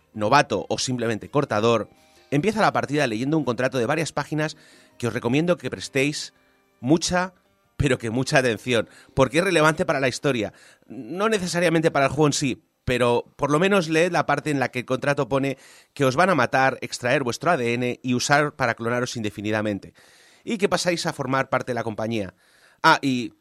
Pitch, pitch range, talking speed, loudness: 135 Hz, 120-155 Hz, 185 wpm, -23 LUFS